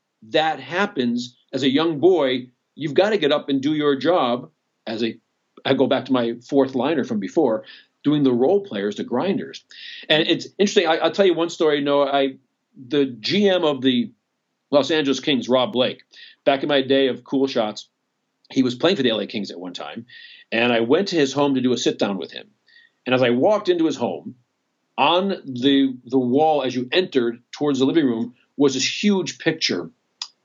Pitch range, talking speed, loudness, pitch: 130-160 Hz, 205 wpm, -20 LUFS, 140 Hz